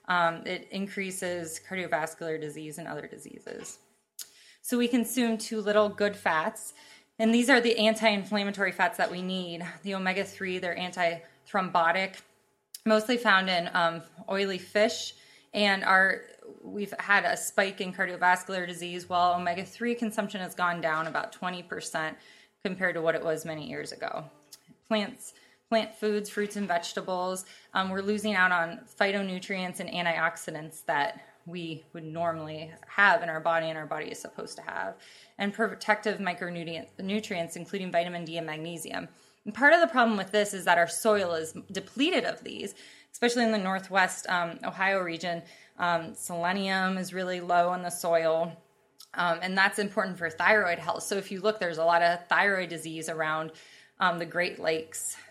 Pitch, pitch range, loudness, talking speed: 185 Hz, 170-210 Hz, -28 LUFS, 160 wpm